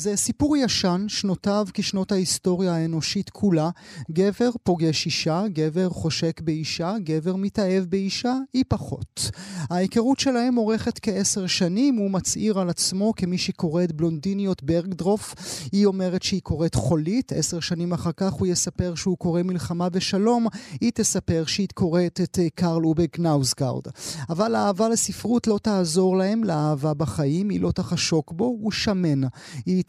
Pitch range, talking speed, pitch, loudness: 170-205 Hz, 145 wpm, 185 Hz, -23 LUFS